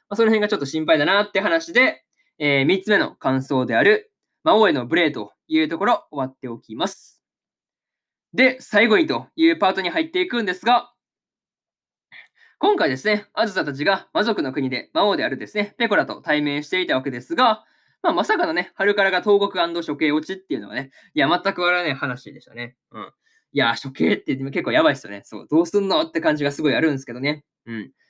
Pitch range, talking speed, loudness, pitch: 140-230 Hz, 410 characters per minute, -20 LUFS, 180 Hz